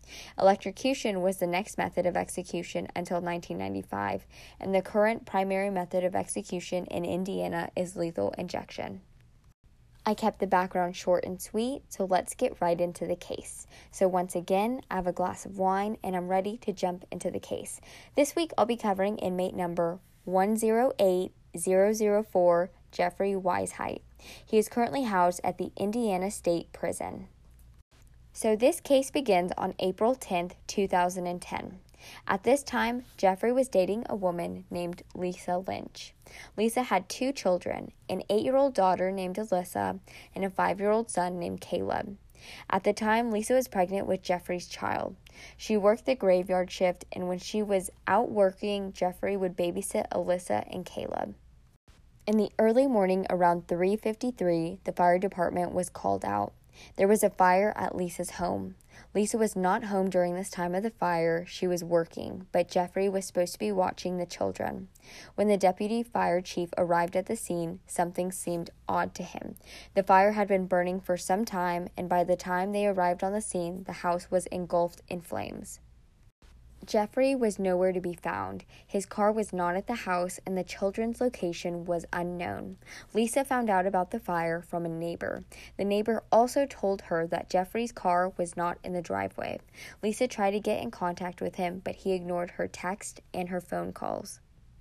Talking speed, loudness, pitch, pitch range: 170 wpm, -29 LUFS, 185 Hz, 175-205 Hz